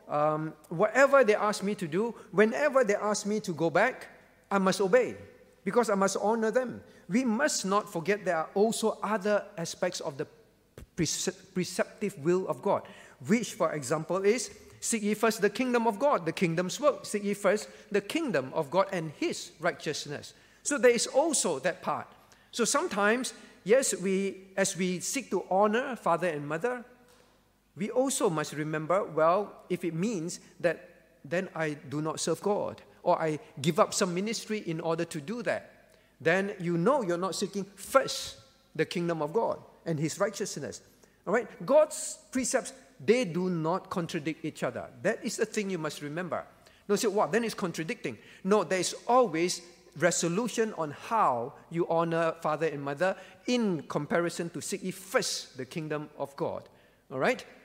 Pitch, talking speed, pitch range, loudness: 195 Hz, 175 wpm, 170-220 Hz, -30 LUFS